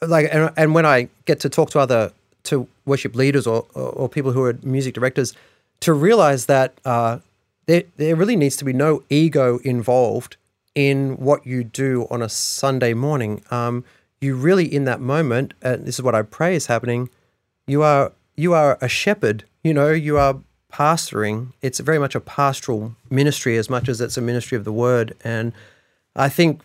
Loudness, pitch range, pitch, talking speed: -19 LUFS, 120-150 Hz, 130 Hz, 190 wpm